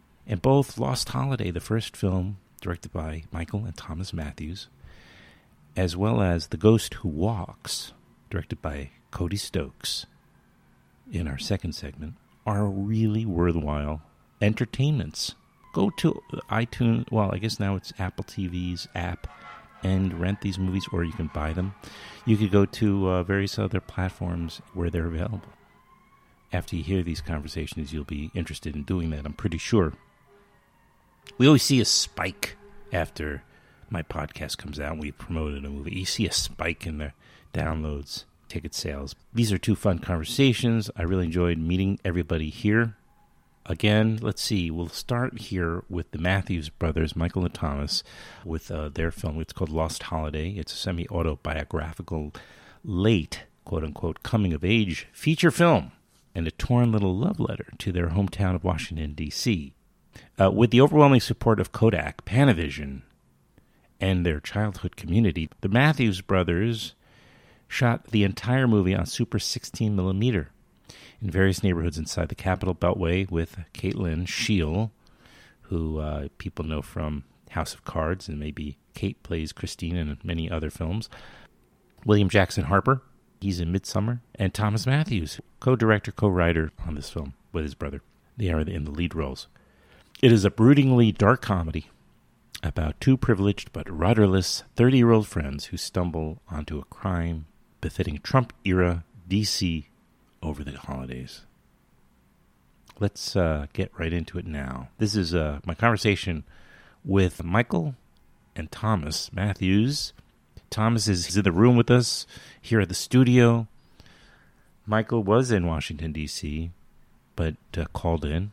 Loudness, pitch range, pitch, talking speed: -26 LUFS, 80-110 Hz, 95 Hz, 145 wpm